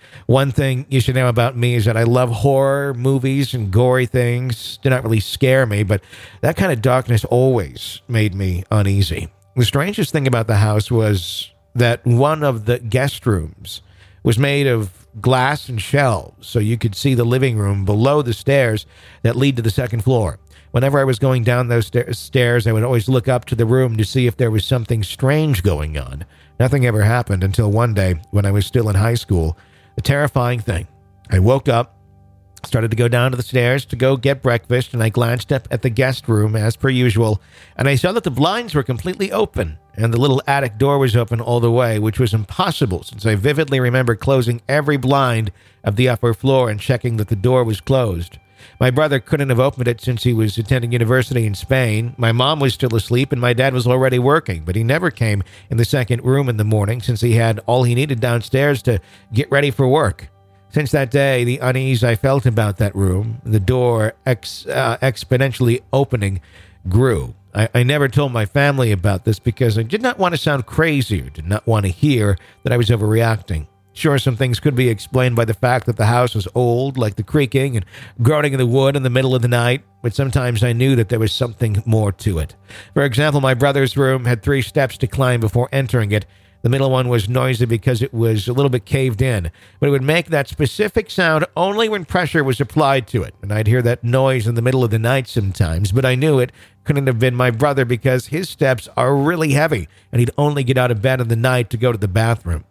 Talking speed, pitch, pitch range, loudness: 225 wpm, 120 Hz, 110-135 Hz, -17 LUFS